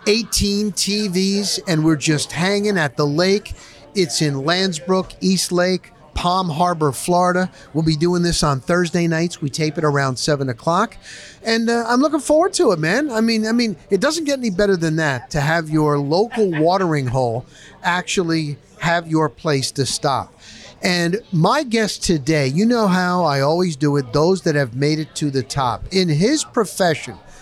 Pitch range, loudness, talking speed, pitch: 150-200 Hz, -18 LUFS, 180 wpm, 175 Hz